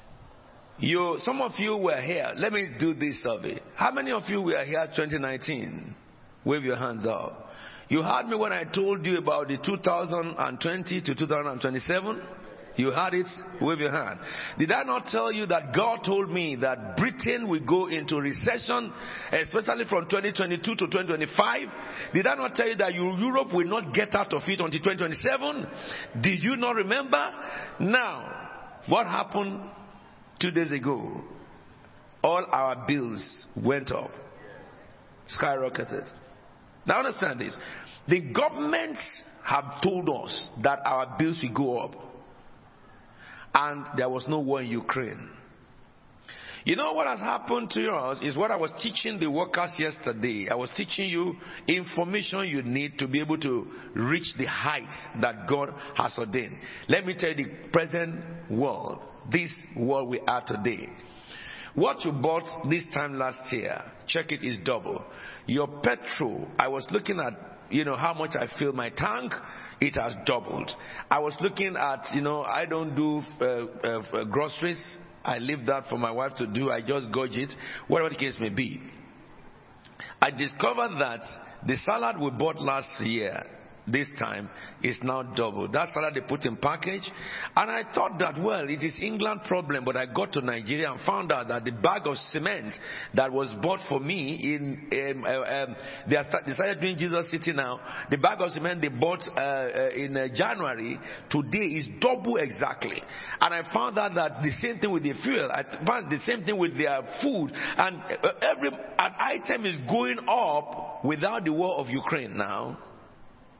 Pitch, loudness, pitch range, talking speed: 155 Hz, -28 LUFS, 135-180 Hz, 170 wpm